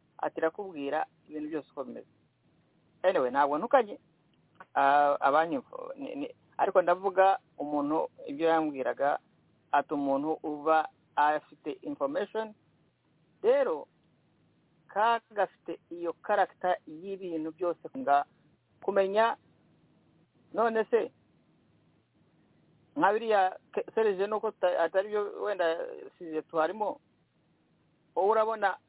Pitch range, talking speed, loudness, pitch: 155-220 Hz, 80 wpm, -30 LUFS, 190 Hz